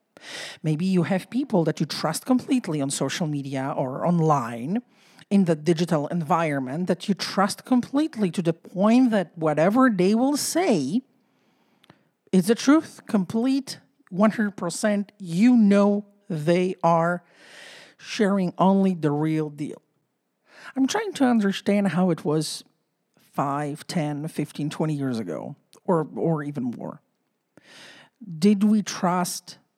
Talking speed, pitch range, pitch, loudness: 125 wpm, 160-215 Hz, 185 Hz, -23 LUFS